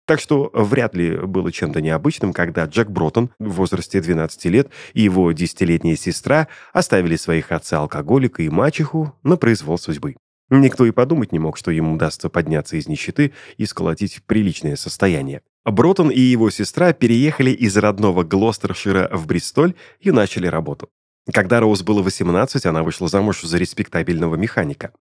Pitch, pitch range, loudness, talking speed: 100 Hz, 85-125 Hz, -18 LUFS, 155 wpm